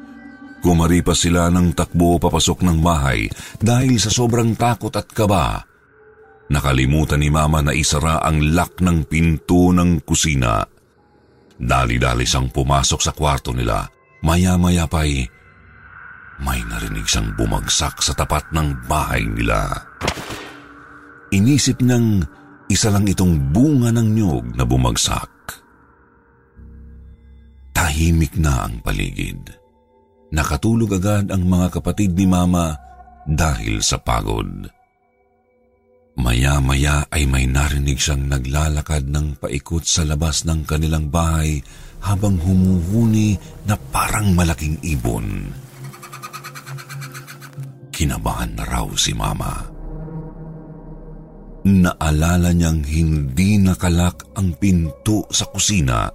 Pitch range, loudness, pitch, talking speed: 75-105 Hz, -18 LUFS, 85 Hz, 105 wpm